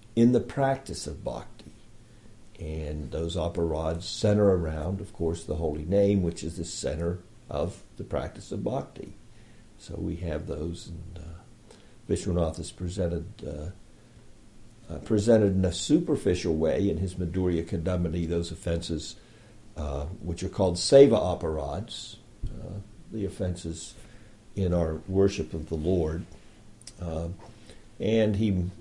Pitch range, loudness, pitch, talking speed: 85-110 Hz, -28 LUFS, 95 Hz, 135 wpm